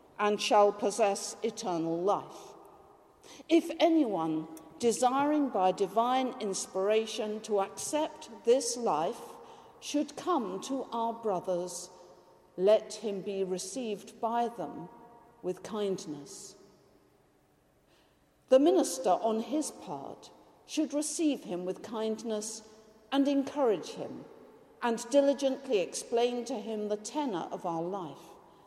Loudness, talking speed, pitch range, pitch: -31 LUFS, 105 wpm, 195-275 Hz, 225 Hz